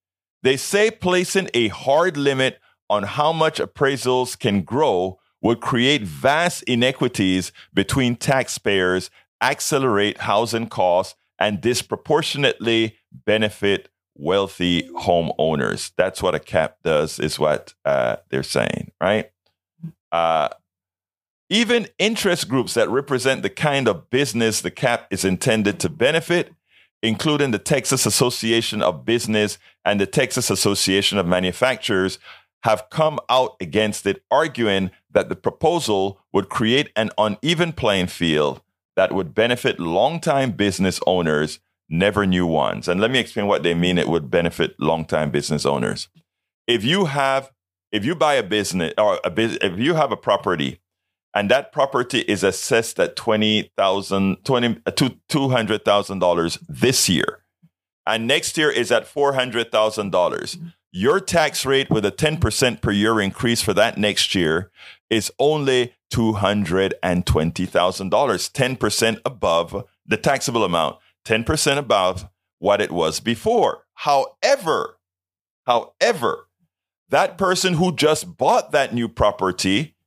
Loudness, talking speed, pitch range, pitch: -20 LUFS, 130 wpm, 95-135 Hz, 110 Hz